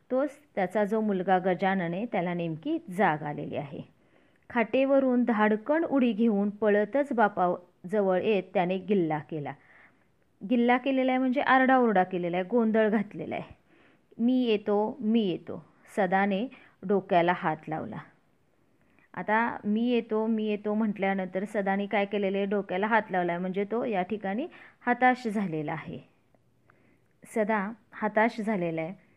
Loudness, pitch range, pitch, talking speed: -28 LUFS, 185-235 Hz, 210 Hz, 130 wpm